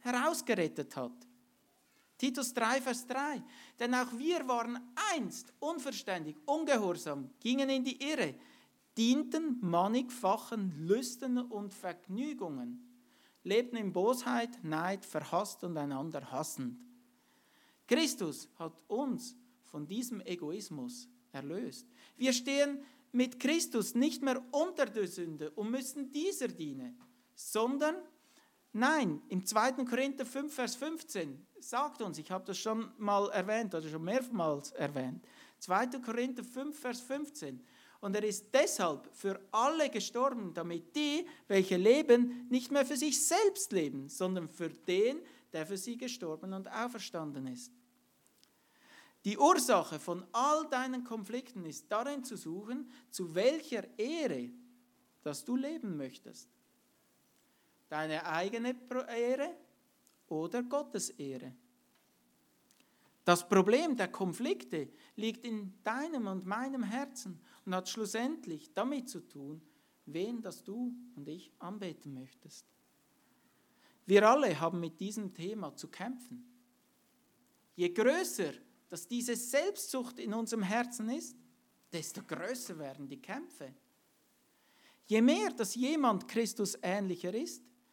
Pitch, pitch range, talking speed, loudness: 240 Hz, 185-265 Hz, 120 wpm, -35 LUFS